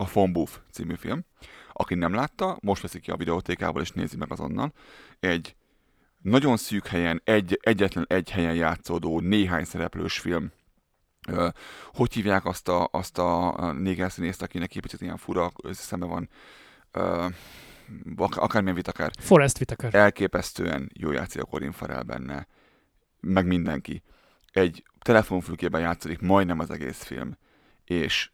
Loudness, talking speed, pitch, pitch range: -26 LUFS, 135 wpm, 90 Hz, 85-100 Hz